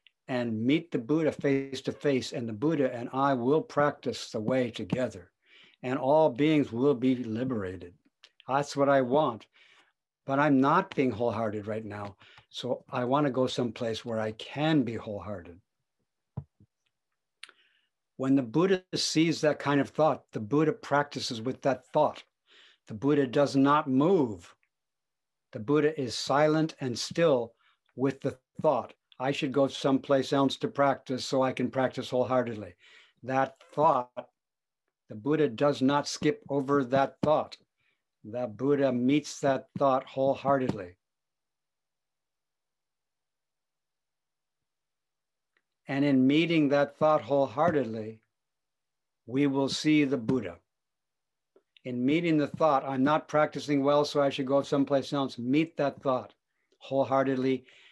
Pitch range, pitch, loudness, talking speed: 125-145 Hz, 135 Hz, -28 LUFS, 135 wpm